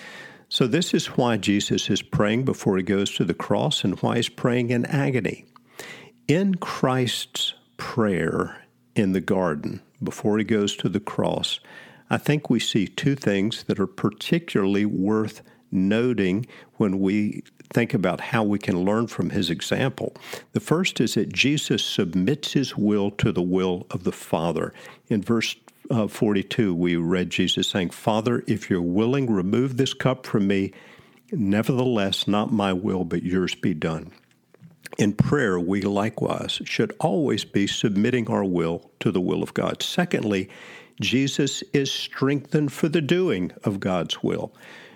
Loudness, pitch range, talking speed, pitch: -24 LUFS, 100-130 Hz, 155 wpm, 110 Hz